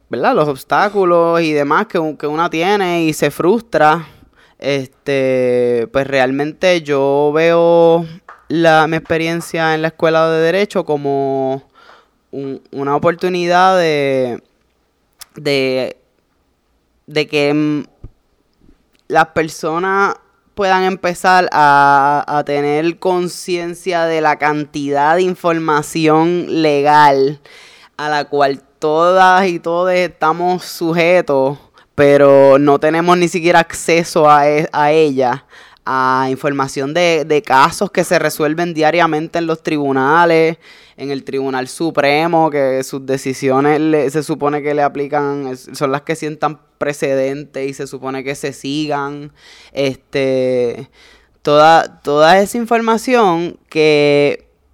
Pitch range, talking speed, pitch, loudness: 140-170 Hz, 120 wpm, 150 Hz, -14 LUFS